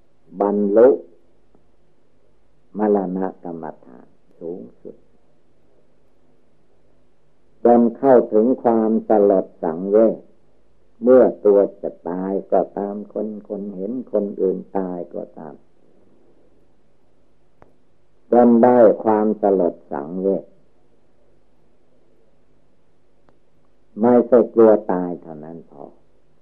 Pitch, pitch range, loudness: 100 Hz, 95-110 Hz, -17 LUFS